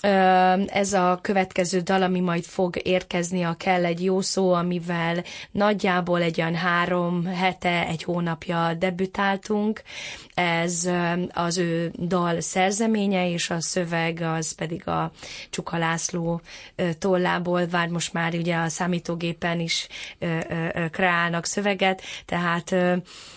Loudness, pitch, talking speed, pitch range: -24 LUFS, 175 Hz, 120 wpm, 170-185 Hz